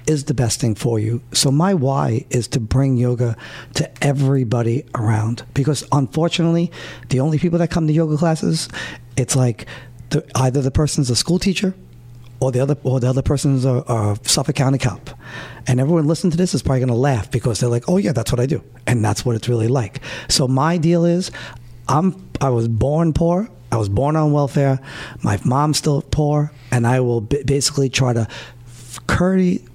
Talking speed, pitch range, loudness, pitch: 200 wpm, 120-150 Hz, -18 LUFS, 135 Hz